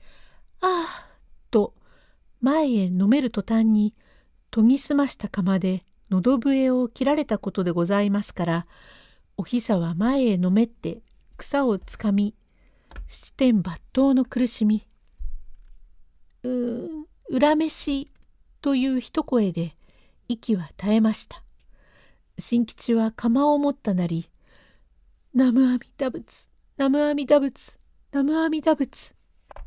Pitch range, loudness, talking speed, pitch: 195-275 Hz, -23 LUFS, 210 characters per minute, 235 Hz